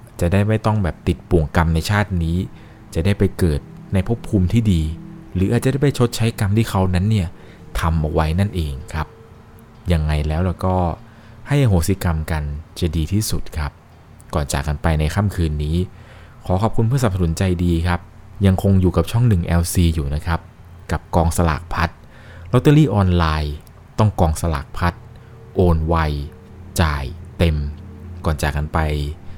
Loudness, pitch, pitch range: -20 LUFS, 90 Hz, 80-105 Hz